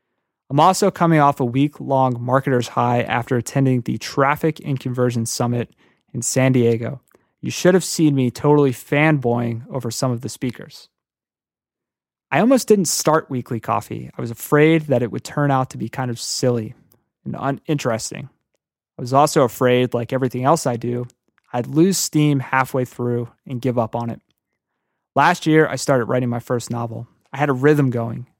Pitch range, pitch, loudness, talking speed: 120-145 Hz, 130 Hz, -19 LUFS, 180 wpm